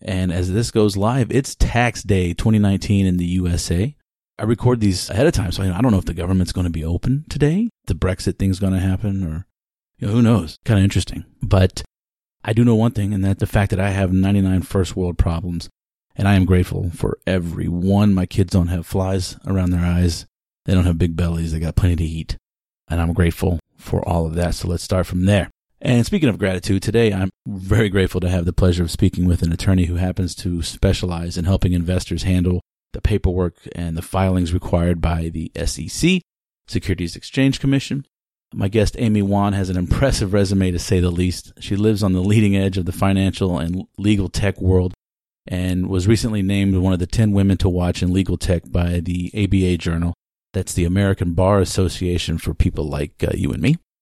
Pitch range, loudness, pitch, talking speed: 90-100 Hz, -19 LUFS, 95 Hz, 210 wpm